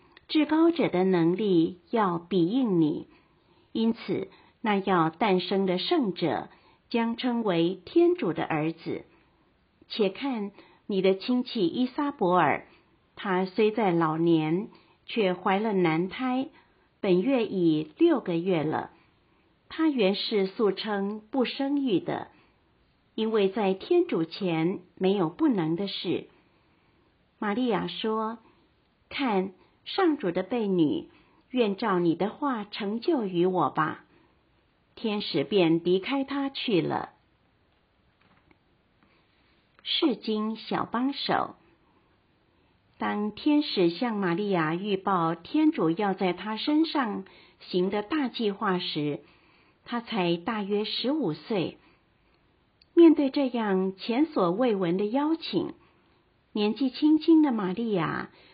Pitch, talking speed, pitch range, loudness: 210 Hz, 160 characters per minute, 185-260 Hz, -27 LUFS